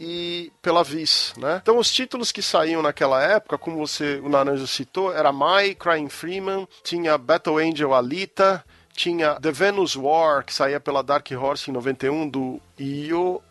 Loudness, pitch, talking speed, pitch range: -22 LUFS, 160 Hz, 165 wpm, 140-180 Hz